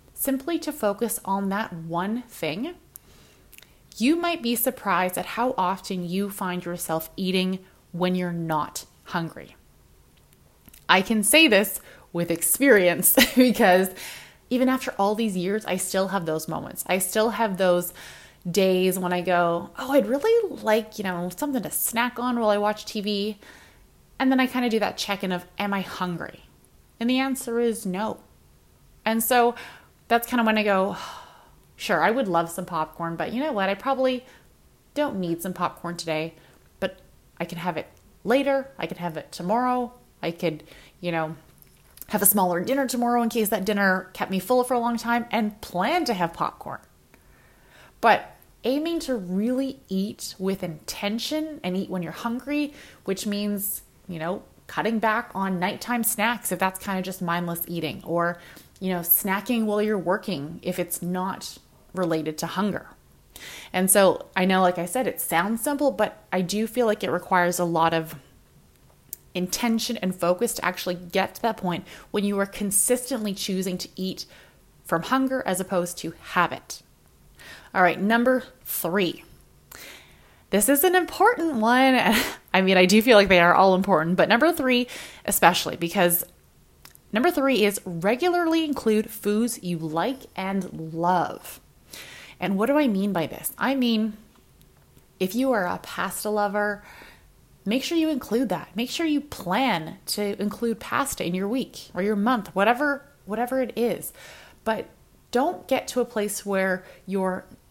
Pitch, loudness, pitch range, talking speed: 200 Hz, -24 LUFS, 180-240 Hz, 170 wpm